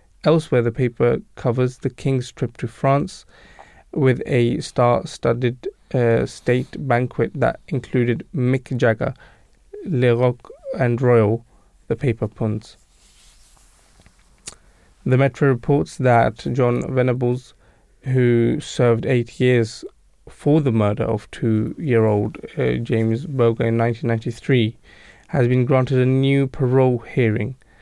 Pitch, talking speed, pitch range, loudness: 120 Hz, 115 wpm, 115-130 Hz, -20 LUFS